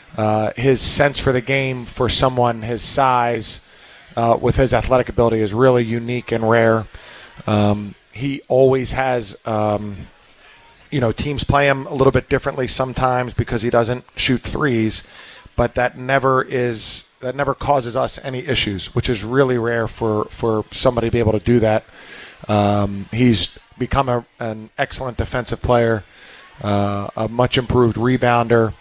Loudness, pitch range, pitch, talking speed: -18 LUFS, 110-130 Hz, 120 Hz, 160 wpm